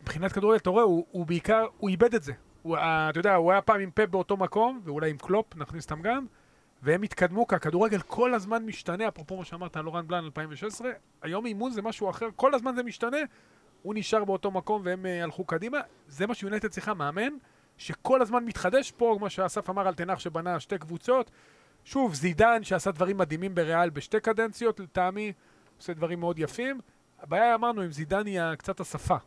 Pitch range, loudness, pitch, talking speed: 175-225 Hz, -28 LUFS, 195 Hz, 190 wpm